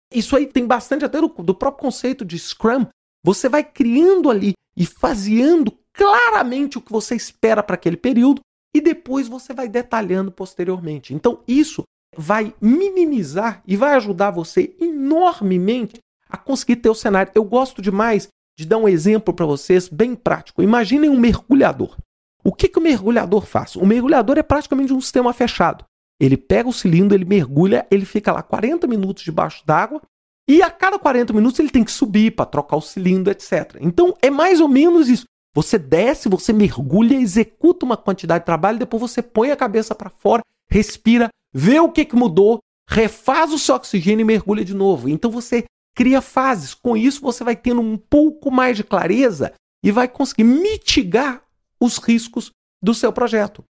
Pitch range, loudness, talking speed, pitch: 200-270 Hz, -17 LUFS, 175 wpm, 235 Hz